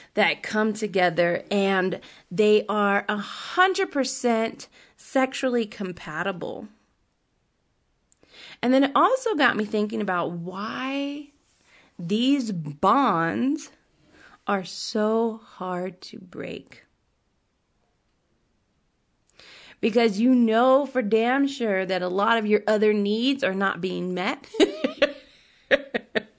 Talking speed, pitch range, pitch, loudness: 95 wpm, 195-265 Hz, 220 Hz, -24 LUFS